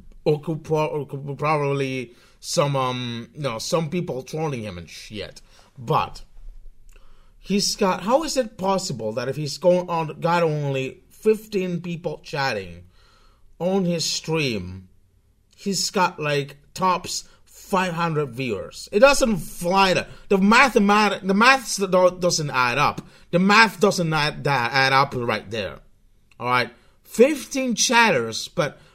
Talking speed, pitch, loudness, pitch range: 130 wpm, 160 Hz, -21 LUFS, 130-190 Hz